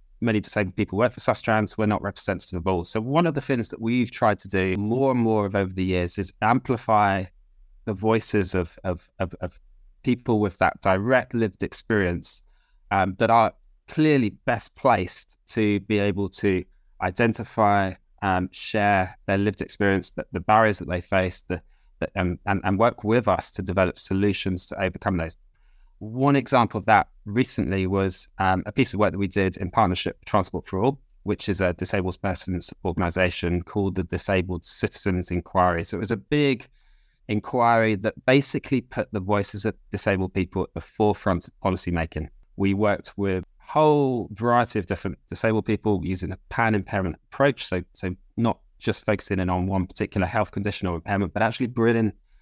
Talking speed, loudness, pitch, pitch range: 185 wpm, -24 LUFS, 100 Hz, 95-110 Hz